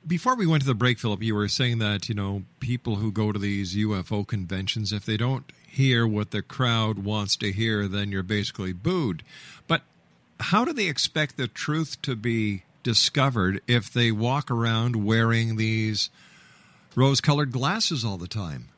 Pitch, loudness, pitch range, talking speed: 115 Hz, -25 LUFS, 105-130 Hz, 180 wpm